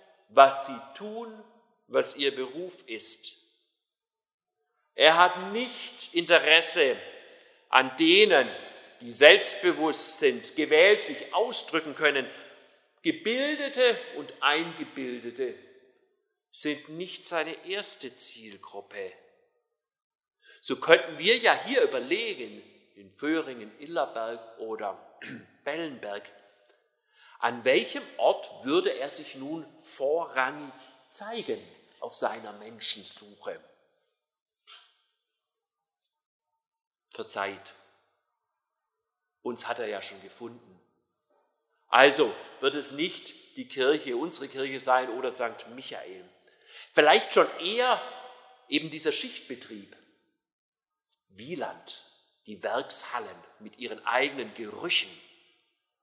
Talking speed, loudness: 90 wpm, -26 LUFS